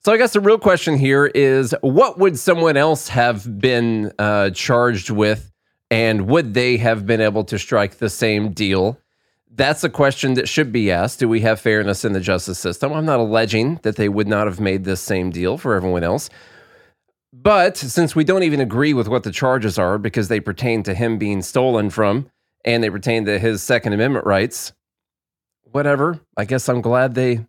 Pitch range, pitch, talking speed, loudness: 105-135 Hz, 115 Hz, 200 wpm, -18 LUFS